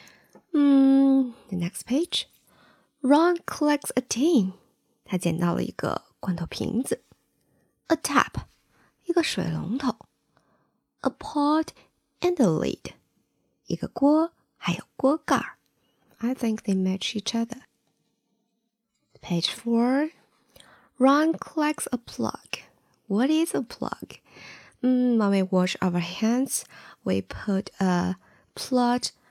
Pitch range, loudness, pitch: 195-285 Hz, -25 LUFS, 245 Hz